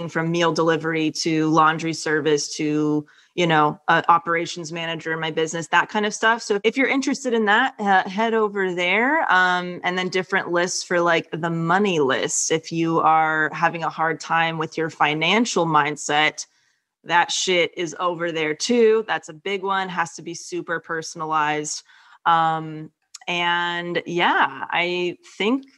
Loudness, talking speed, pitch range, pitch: -21 LUFS, 165 wpm, 160-185 Hz, 170 Hz